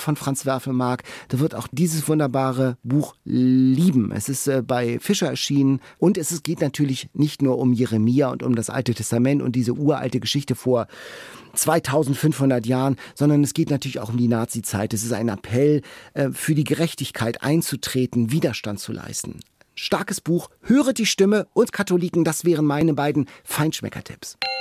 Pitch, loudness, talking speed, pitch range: 135 Hz, -22 LUFS, 160 wpm, 125-155 Hz